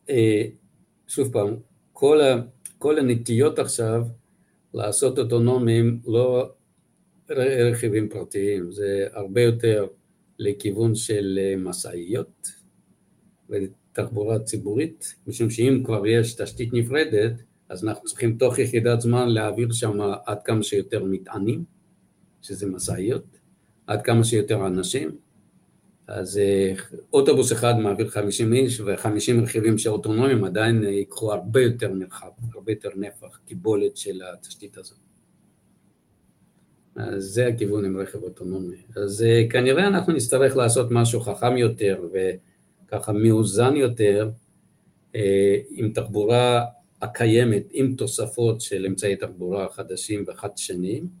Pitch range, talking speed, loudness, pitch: 100-120 Hz, 110 wpm, -23 LUFS, 110 Hz